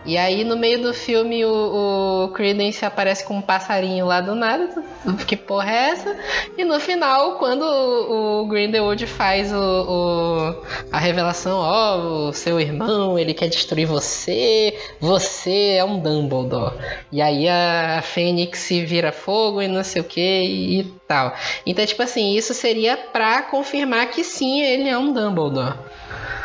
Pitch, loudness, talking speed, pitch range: 200 Hz, -20 LUFS, 160 wpm, 175-230 Hz